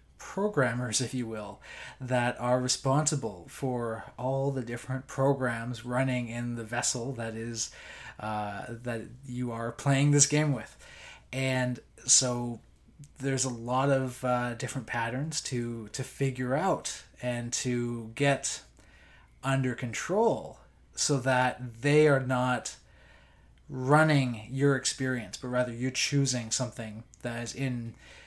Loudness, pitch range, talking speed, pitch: -30 LUFS, 120-135 Hz, 125 wpm, 125 Hz